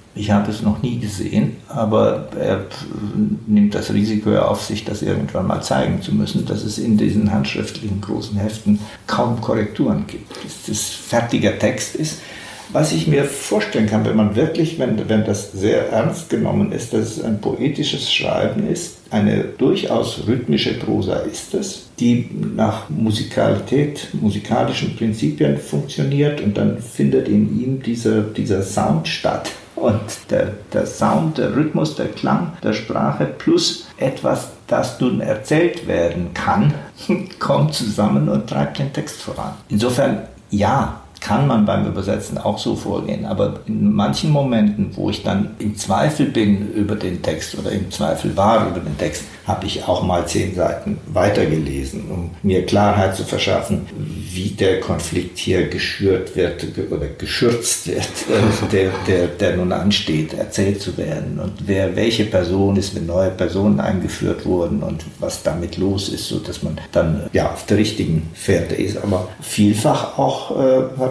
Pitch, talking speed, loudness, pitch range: 105 Hz, 155 wpm, -19 LUFS, 95-110 Hz